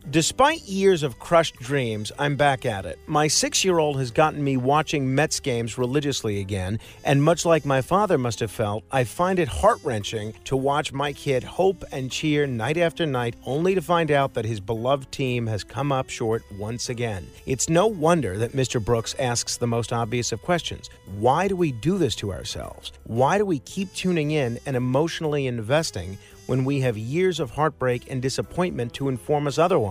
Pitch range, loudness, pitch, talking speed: 120-155 Hz, -24 LUFS, 135 Hz, 195 wpm